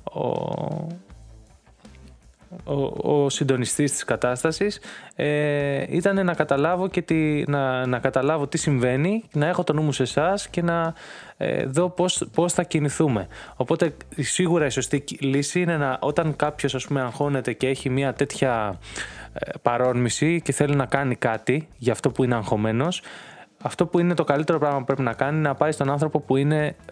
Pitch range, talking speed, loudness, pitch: 130-165 Hz, 170 wpm, -23 LUFS, 145 Hz